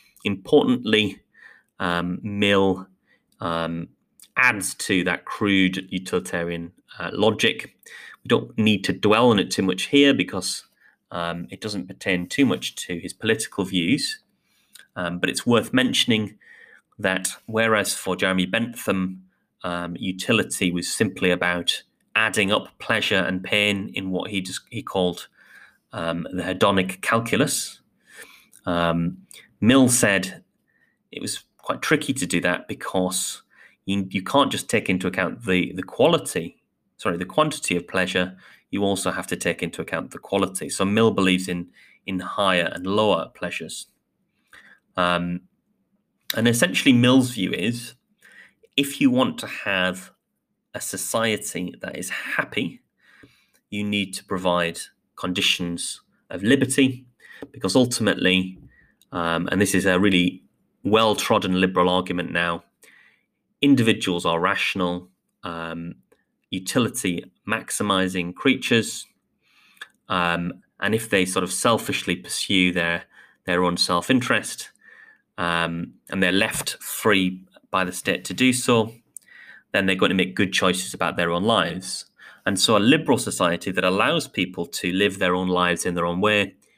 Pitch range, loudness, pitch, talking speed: 90-110 Hz, -22 LUFS, 95 Hz, 135 wpm